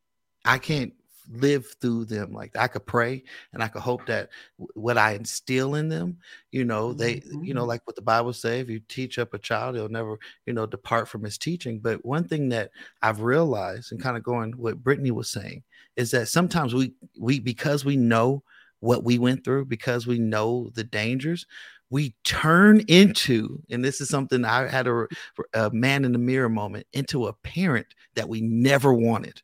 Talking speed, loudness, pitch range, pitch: 200 wpm, -24 LUFS, 115-135 Hz, 120 Hz